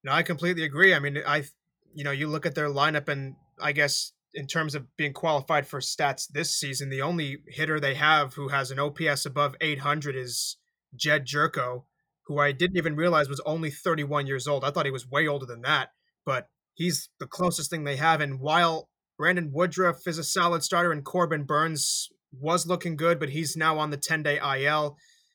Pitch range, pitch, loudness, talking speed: 145-170 Hz, 150 Hz, -26 LUFS, 205 wpm